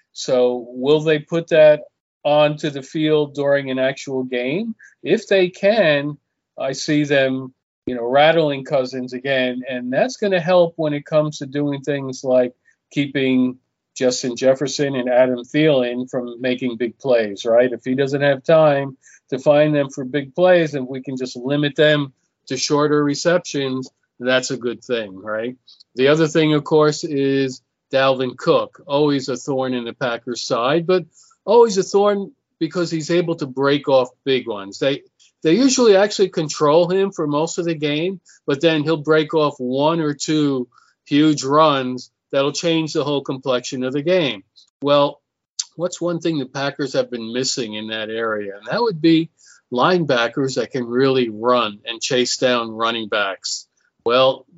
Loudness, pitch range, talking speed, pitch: -19 LUFS, 130-155 Hz, 170 wpm, 140 Hz